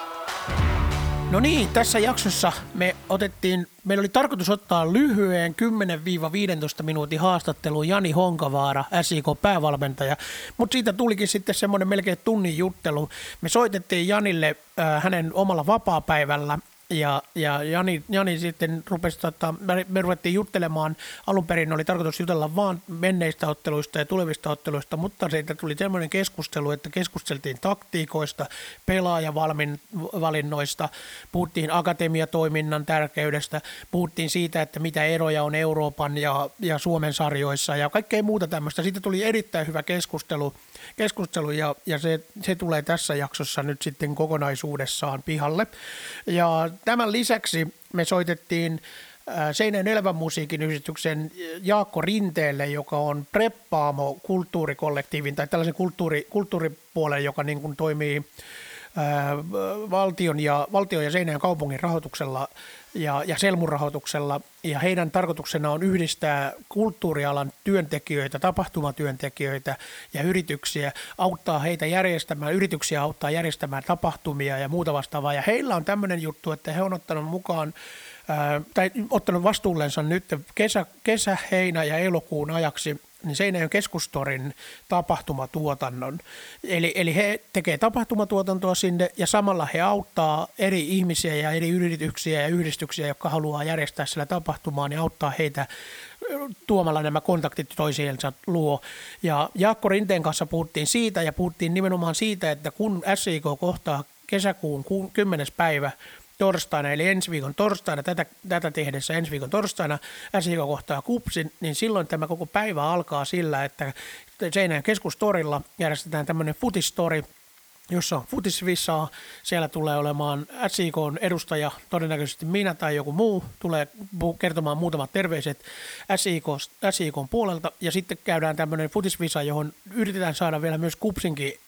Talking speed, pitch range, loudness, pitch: 130 wpm, 150-185 Hz, -25 LUFS, 165 Hz